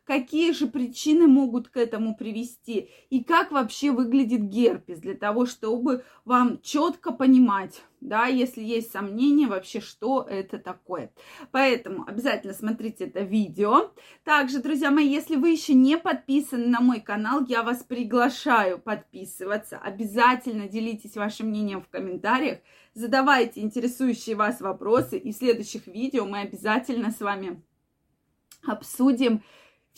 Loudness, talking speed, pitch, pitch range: -24 LUFS, 130 wpm, 240 Hz, 215-270 Hz